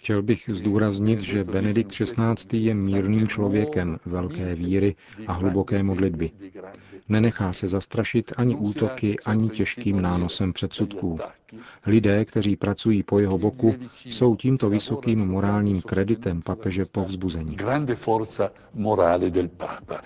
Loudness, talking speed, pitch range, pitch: -24 LUFS, 110 wpm, 95-110 Hz, 100 Hz